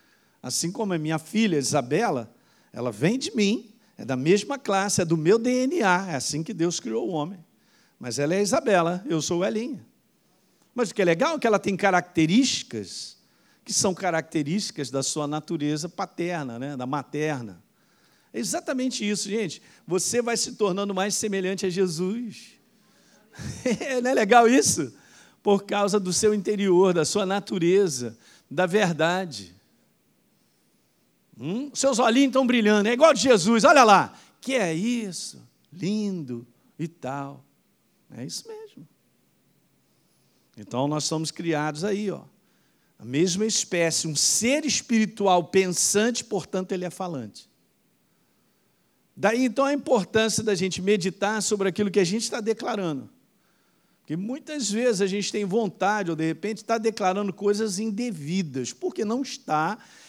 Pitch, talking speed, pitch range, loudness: 195 Hz, 150 wpm, 170-220 Hz, -24 LUFS